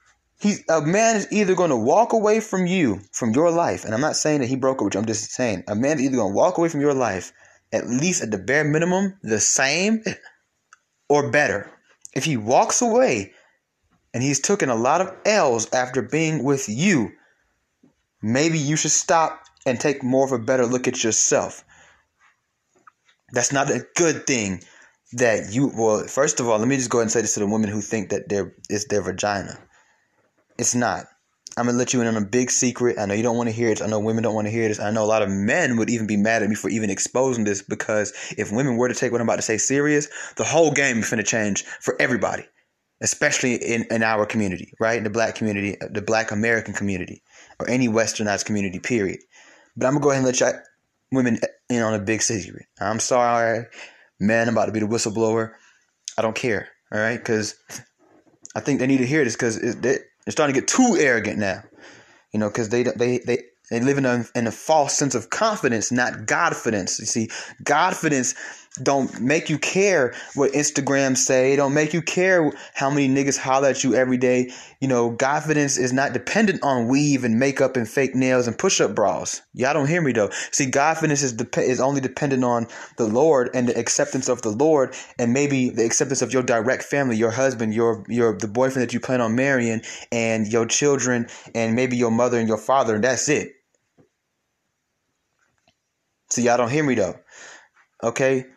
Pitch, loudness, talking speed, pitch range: 125 Hz, -21 LUFS, 215 wpm, 115-140 Hz